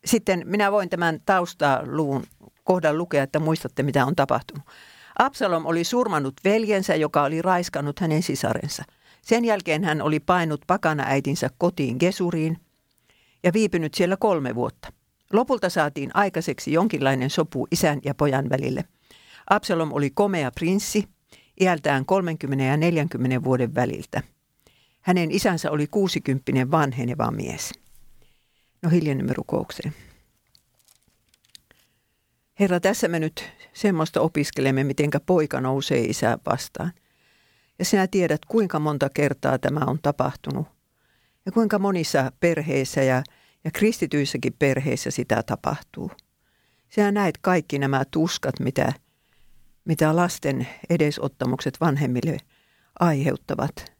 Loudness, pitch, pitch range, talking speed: -23 LUFS, 155 Hz, 135-180 Hz, 115 wpm